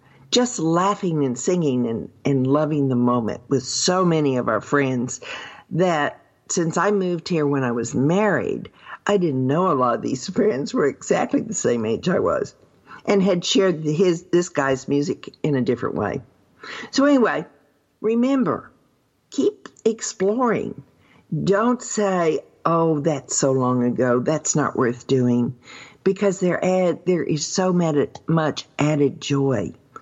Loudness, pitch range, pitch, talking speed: -21 LUFS, 135-195 Hz, 160 Hz, 145 wpm